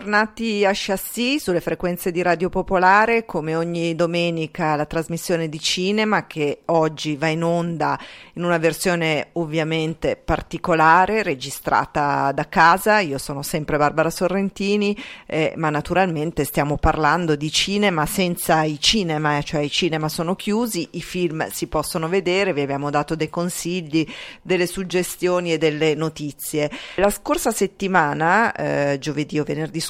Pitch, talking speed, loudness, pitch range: 170 Hz, 145 wpm, -20 LUFS, 155-185 Hz